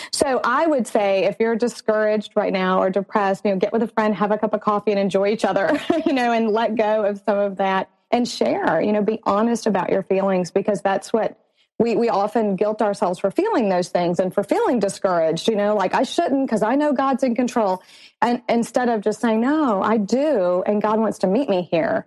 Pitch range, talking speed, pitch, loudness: 200-235 Hz, 235 wpm, 215 Hz, -20 LUFS